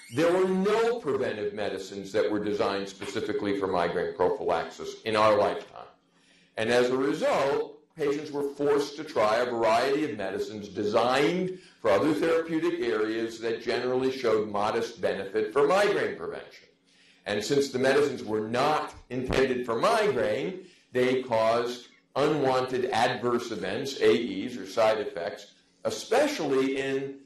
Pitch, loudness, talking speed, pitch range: 130 Hz, -27 LUFS, 135 wpm, 110-180 Hz